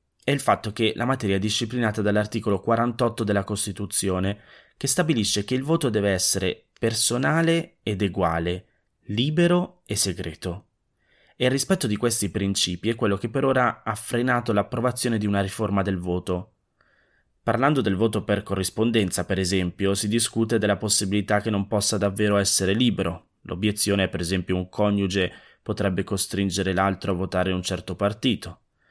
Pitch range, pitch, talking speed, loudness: 95-115 Hz, 105 Hz, 155 wpm, -24 LUFS